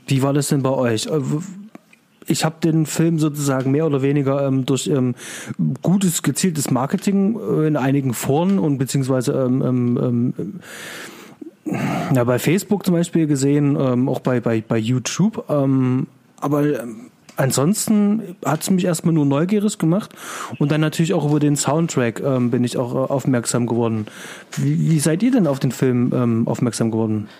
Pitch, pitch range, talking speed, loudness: 145 Hz, 130-165 Hz, 140 wpm, -19 LUFS